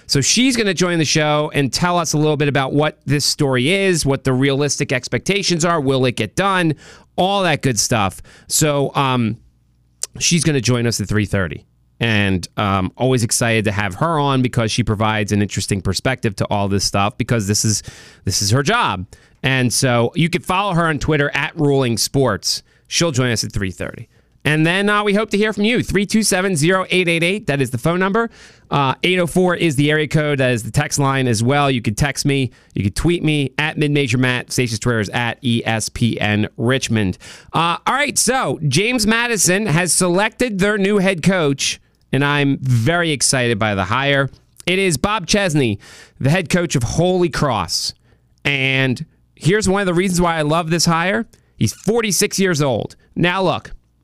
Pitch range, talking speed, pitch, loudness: 115-175 Hz, 190 wpm, 140 Hz, -17 LUFS